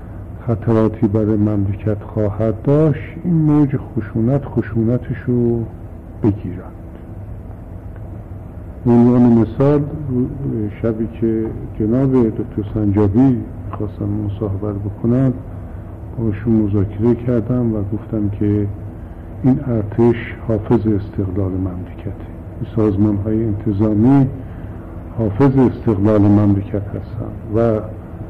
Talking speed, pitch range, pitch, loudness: 90 wpm, 100-115 Hz, 110 Hz, -17 LUFS